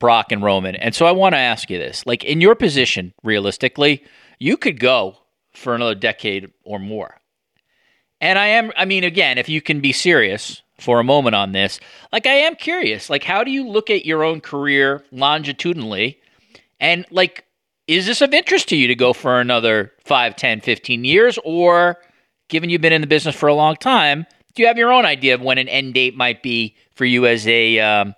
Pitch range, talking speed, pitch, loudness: 120-175 Hz, 210 wpm, 140 Hz, -16 LUFS